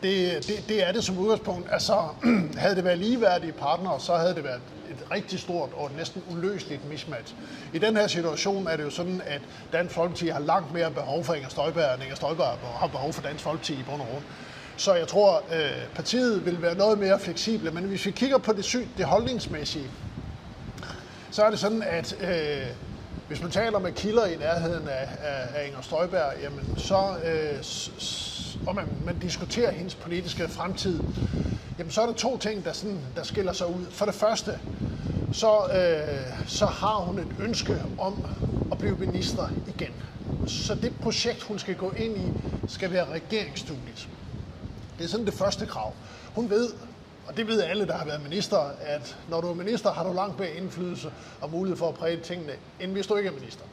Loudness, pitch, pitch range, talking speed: -28 LUFS, 175 Hz, 150-200 Hz, 200 wpm